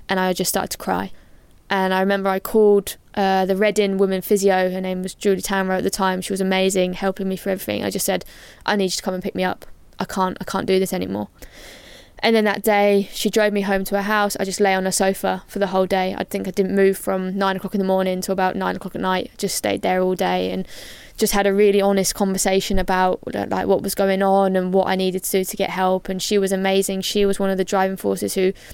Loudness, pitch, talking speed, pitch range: -20 LUFS, 190 Hz, 265 wpm, 185-200 Hz